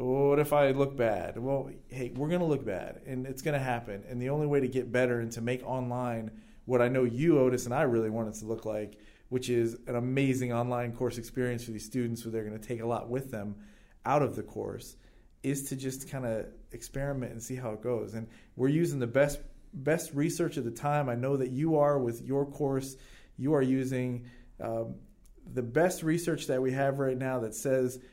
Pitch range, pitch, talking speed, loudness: 115-140 Hz, 125 Hz, 220 wpm, -31 LUFS